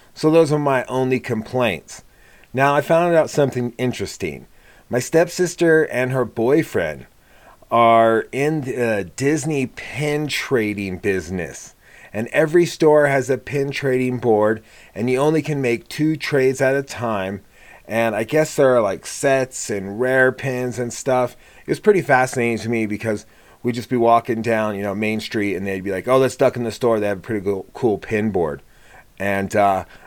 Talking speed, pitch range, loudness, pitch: 180 wpm, 110-140 Hz, -19 LUFS, 125 Hz